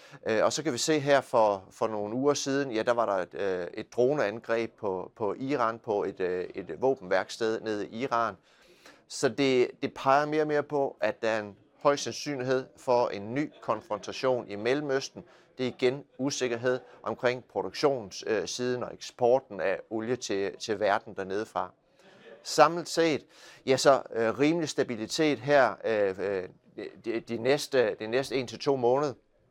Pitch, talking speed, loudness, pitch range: 130 Hz, 165 wpm, -29 LUFS, 115-145 Hz